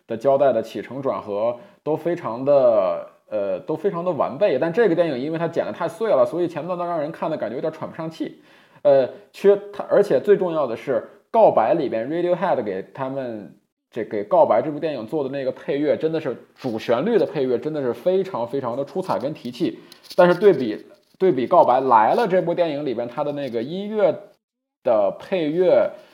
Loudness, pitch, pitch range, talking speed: -21 LUFS, 180 Hz, 155-215 Hz, 310 characters per minute